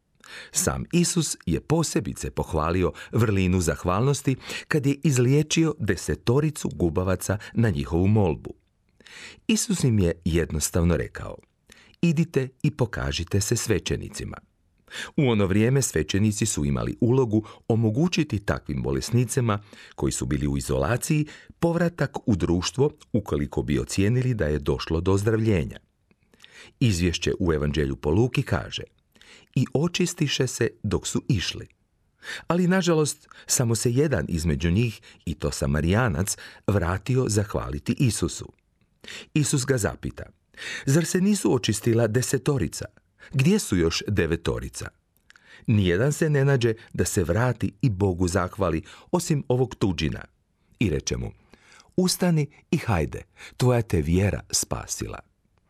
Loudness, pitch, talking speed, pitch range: -24 LUFS, 110 Hz, 120 wpm, 85-140 Hz